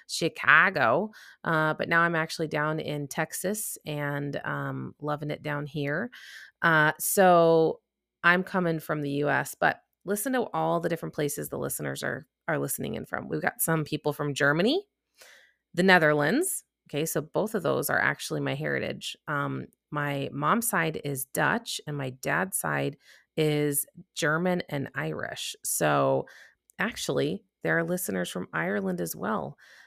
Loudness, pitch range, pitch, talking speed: -27 LUFS, 145-170 Hz, 155 Hz, 155 wpm